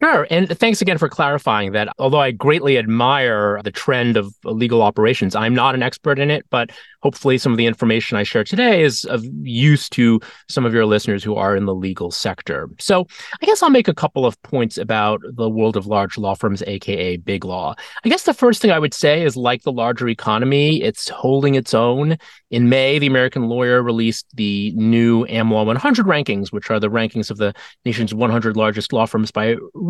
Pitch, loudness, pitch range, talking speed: 120 Hz, -17 LUFS, 110-145 Hz, 210 wpm